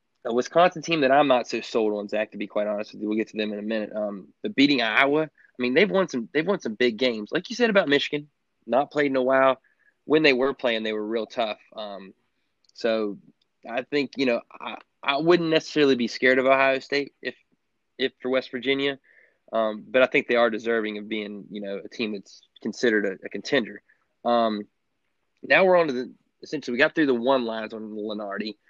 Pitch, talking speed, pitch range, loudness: 130 Hz, 225 wpm, 110-145 Hz, -24 LUFS